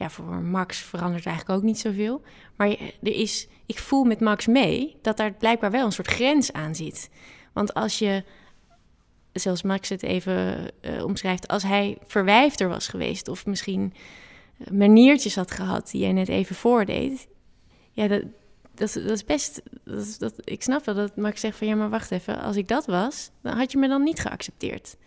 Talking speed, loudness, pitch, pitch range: 190 wpm, -24 LUFS, 205 Hz, 190-225 Hz